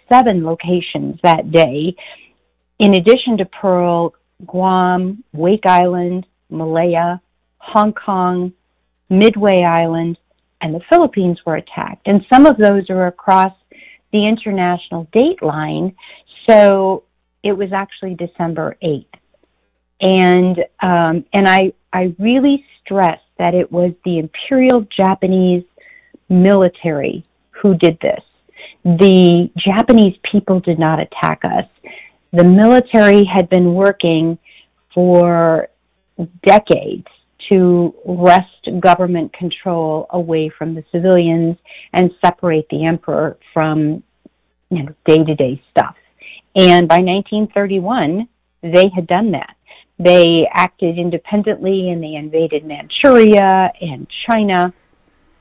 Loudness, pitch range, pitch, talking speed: -13 LUFS, 170-200 Hz, 180 Hz, 110 wpm